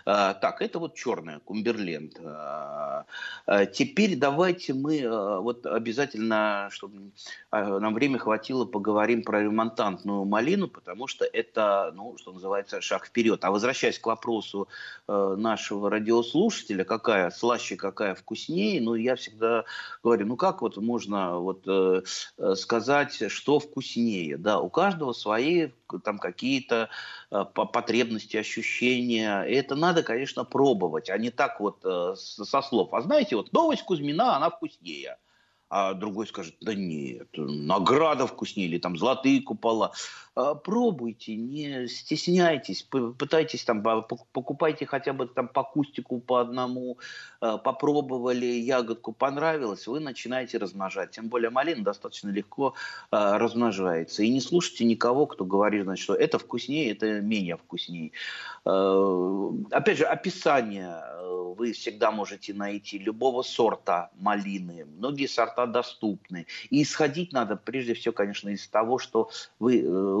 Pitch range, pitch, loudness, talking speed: 105-140 Hz, 115 Hz, -27 LUFS, 125 wpm